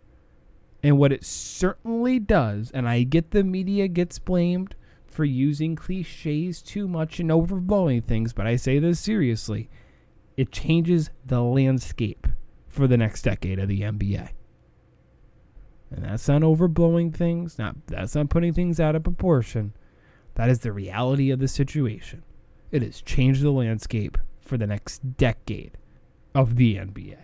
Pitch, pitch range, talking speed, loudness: 130 Hz, 110-165 Hz, 150 wpm, -24 LUFS